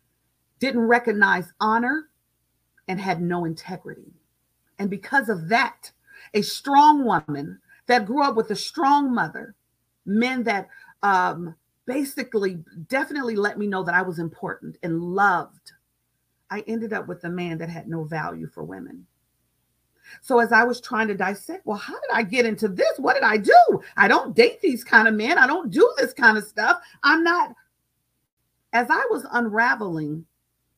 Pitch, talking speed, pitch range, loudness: 225 Hz, 165 wpm, 185-270 Hz, -21 LUFS